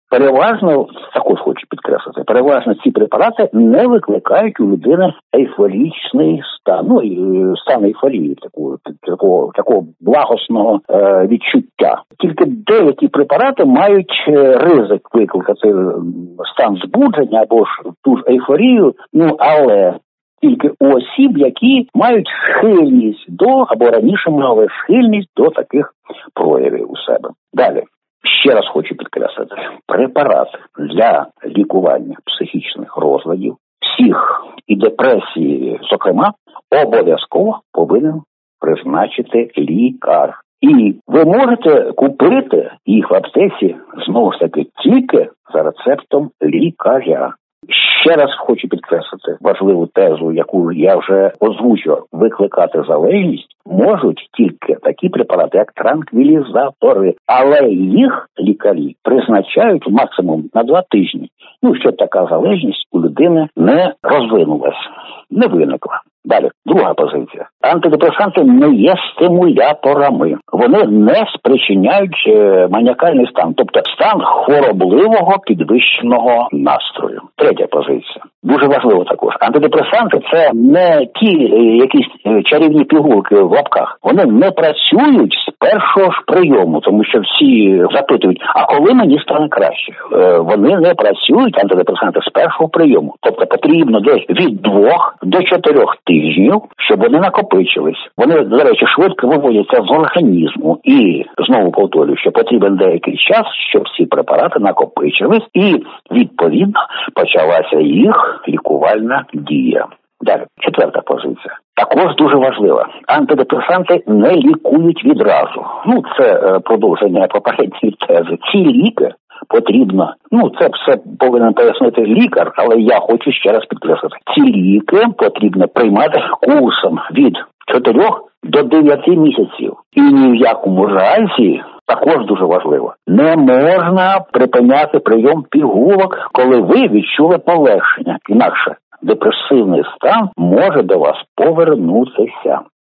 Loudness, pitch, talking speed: -11 LUFS, 290 Hz, 115 wpm